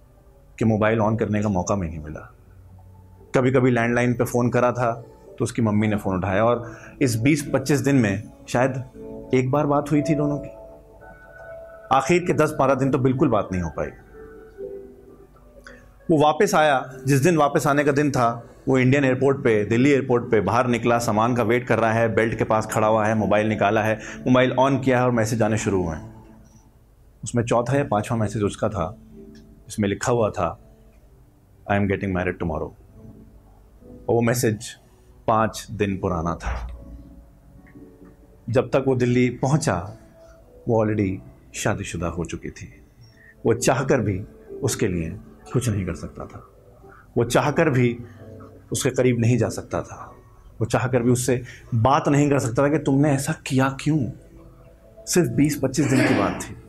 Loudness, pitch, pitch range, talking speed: -22 LUFS, 115 Hz, 105-135 Hz, 170 wpm